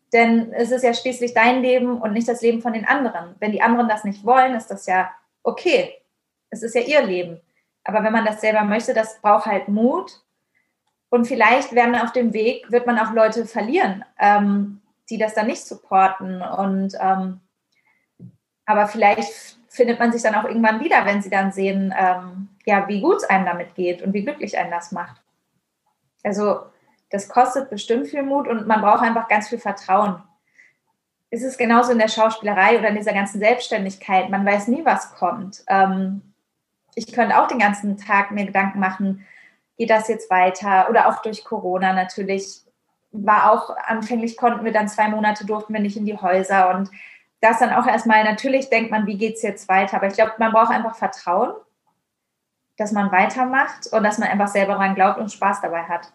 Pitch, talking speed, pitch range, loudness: 215 Hz, 195 wpm, 195-235 Hz, -19 LUFS